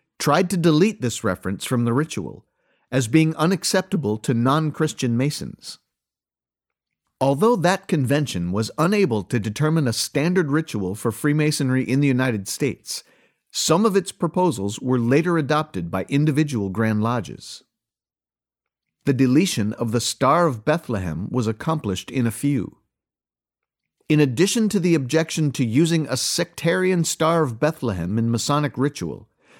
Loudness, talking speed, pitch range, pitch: -21 LUFS, 140 wpm, 115-160 Hz, 140 Hz